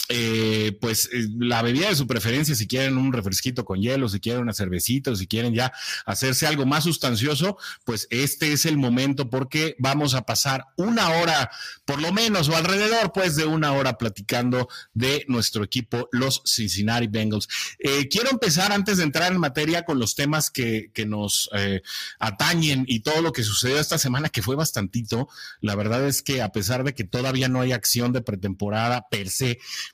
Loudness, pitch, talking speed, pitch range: -23 LUFS, 130 Hz, 190 wpm, 115-150 Hz